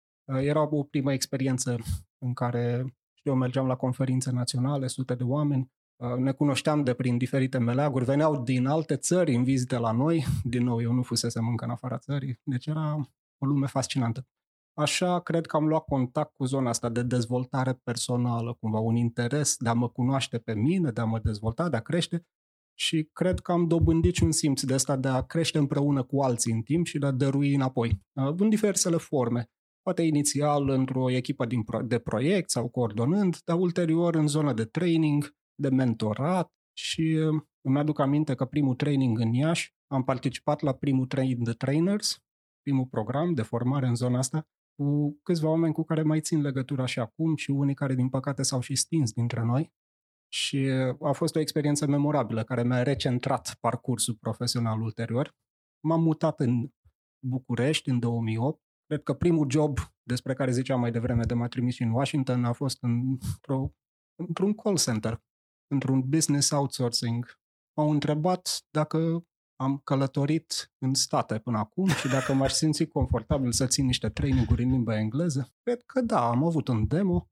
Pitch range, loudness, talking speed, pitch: 120-150 Hz, -27 LUFS, 175 wpm, 135 Hz